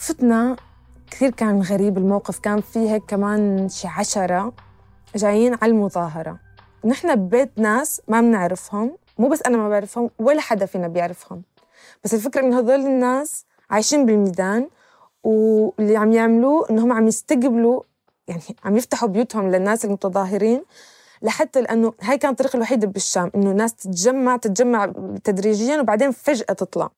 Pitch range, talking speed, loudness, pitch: 200-250 Hz, 140 wpm, -19 LUFS, 220 Hz